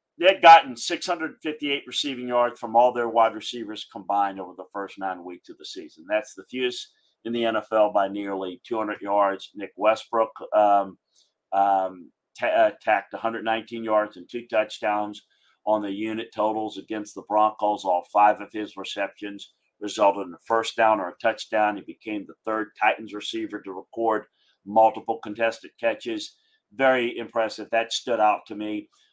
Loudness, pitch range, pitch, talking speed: -24 LUFS, 105-120 Hz, 110 Hz, 165 wpm